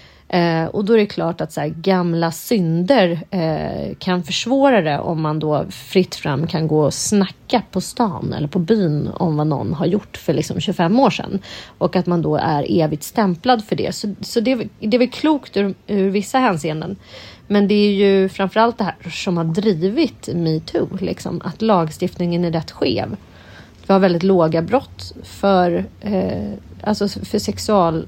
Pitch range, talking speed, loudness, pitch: 165-205 Hz, 185 wpm, -18 LUFS, 185 Hz